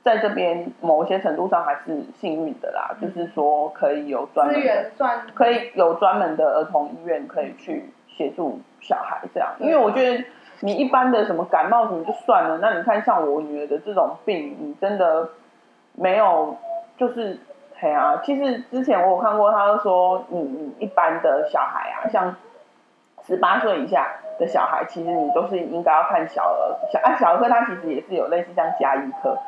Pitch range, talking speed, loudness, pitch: 170-255 Hz, 270 characters per minute, -21 LUFS, 210 Hz